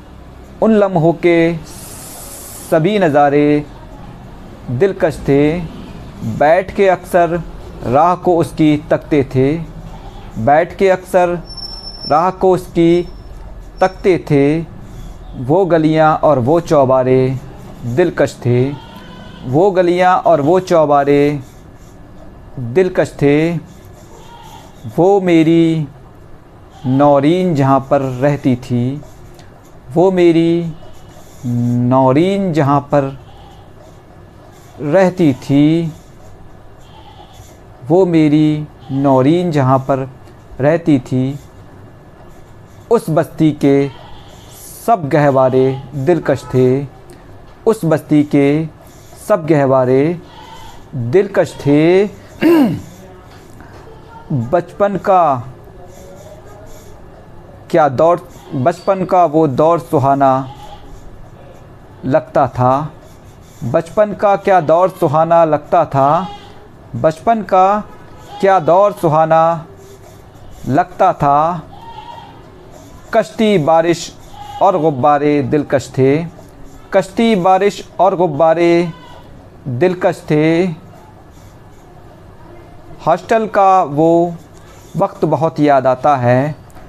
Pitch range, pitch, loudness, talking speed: 130-175 Hz, 150 Hz, -13 LUFS, 80 wpm